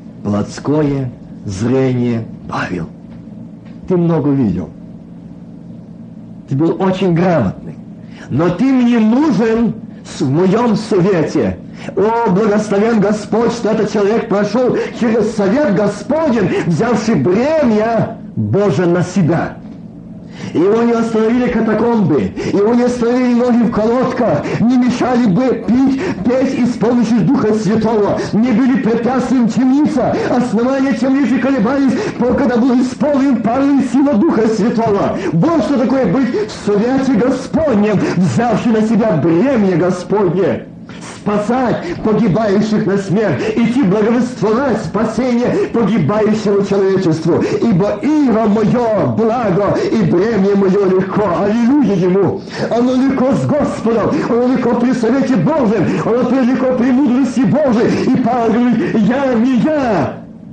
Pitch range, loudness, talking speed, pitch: 205-250 Hz, -13 LUFS, 115 wpm, 225 Hz